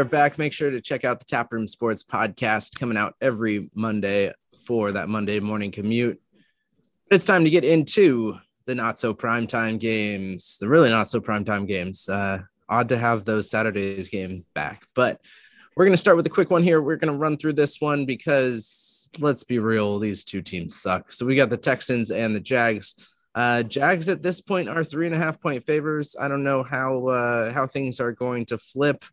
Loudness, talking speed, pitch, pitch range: -23 LUFS, 205 wpm, 120 Hz, 110-145 Hz